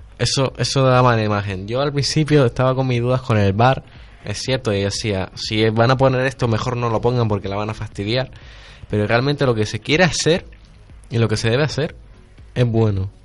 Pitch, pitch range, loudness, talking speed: 120 Hz, 105-130 Hz, -18 LUFS, 220 wpm